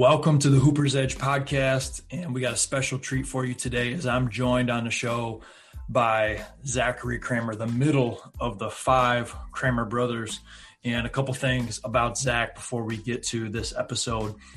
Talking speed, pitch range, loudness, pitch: 175 wpm, 115-130 Hz, -26 LUFS, 120 Hz